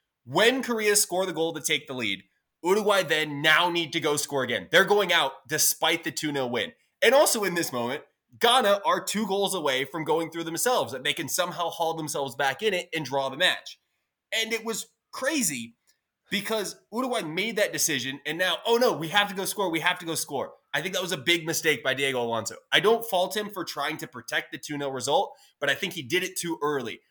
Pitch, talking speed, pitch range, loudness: 165 Hz, 230 wpm, 150-200 Hz, -25 LUFS